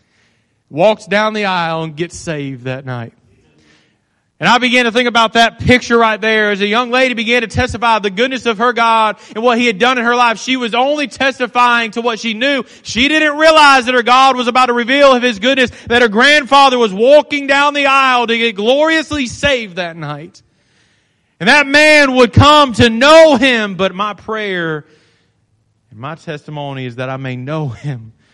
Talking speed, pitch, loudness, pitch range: 200 wpm, 235 Hz, -11 LUFS, 160-255 Hz